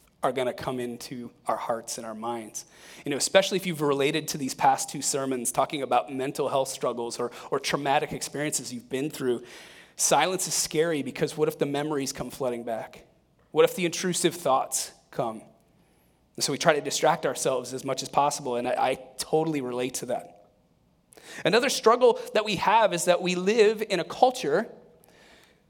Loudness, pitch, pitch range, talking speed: -26 LUFS, 140 Hz, 125-170 Hz, 185 wpm